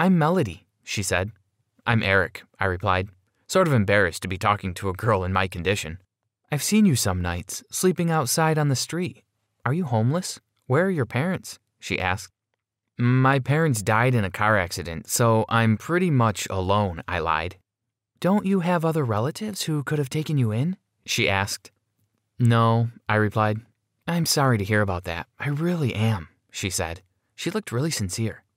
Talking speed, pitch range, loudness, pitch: 175 wpm, 100-150 Hz, -24 LUFS, 115 Hz